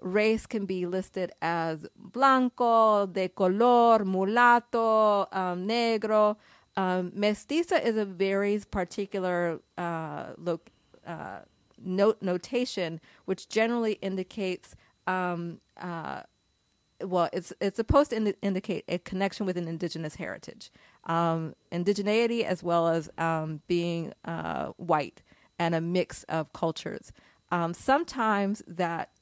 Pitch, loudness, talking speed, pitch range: 190 Hz, -28 LUFS, 115 wpm, 175-220 Hz